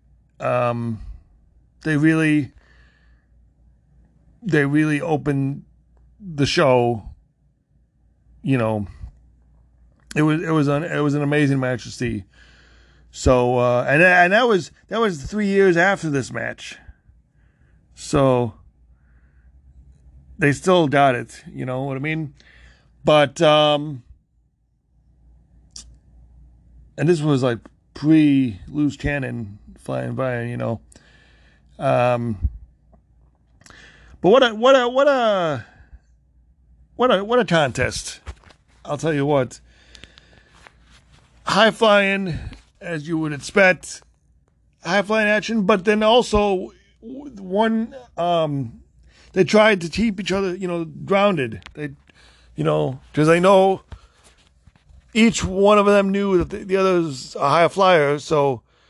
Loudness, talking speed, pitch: -19 LUFS, 120 wpm, 140 Hz